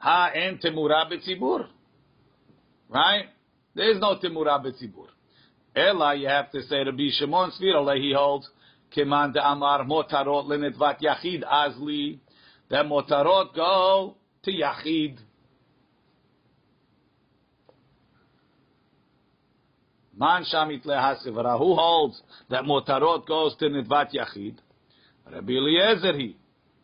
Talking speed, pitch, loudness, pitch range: 95 wpm, 145 Hz, -24 LUFS, 140-160 Hz